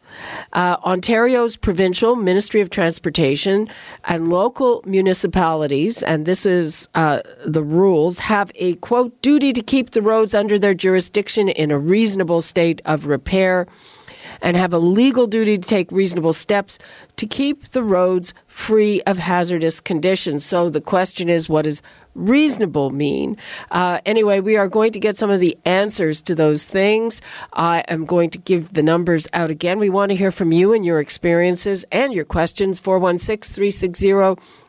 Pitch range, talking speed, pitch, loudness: 170-210 Hz, 160 wpm, 185 Hz, -17 LUFS